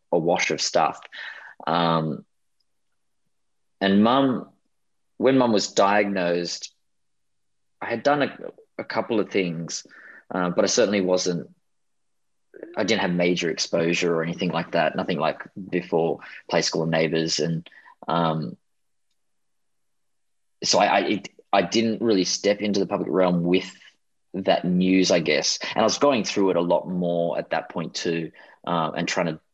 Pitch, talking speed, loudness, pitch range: 90 Hz, 155 wpm, -23 LUFS, 85-100 Hz